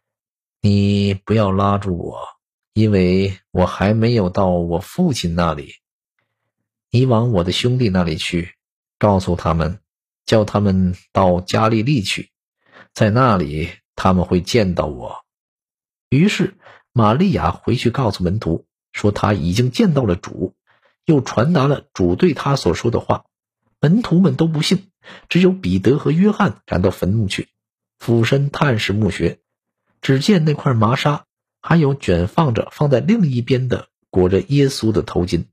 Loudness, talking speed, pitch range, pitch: -17 LUFS, 215 characters per minute, 90-135 Hz, 105 Hz